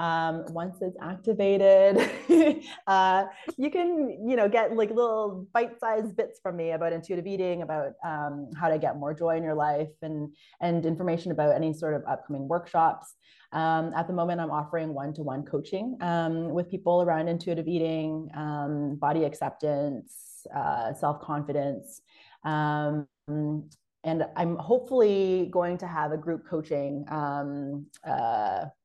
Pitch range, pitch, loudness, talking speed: 150-190 Hz, 165 Hz, -28 LUFS, 145 wpm